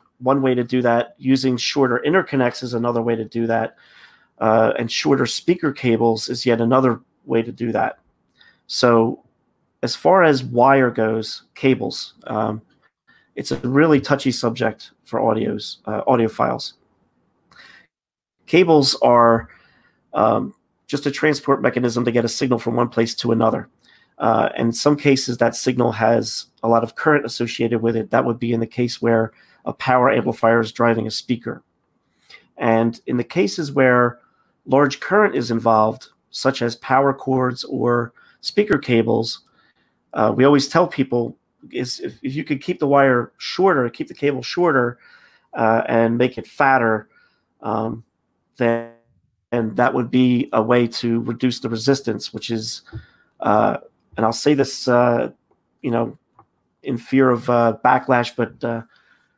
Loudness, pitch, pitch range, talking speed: -19 LUFS, 120 Hz, 115-130 Hz, 160 wpm